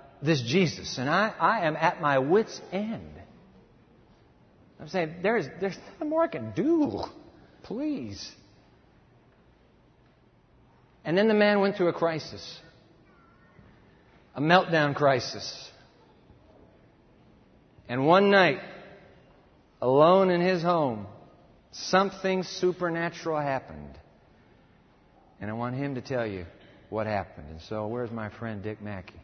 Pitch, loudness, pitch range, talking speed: 155 Hz, -26 LUFS, 115-185 Hz, 115 wpm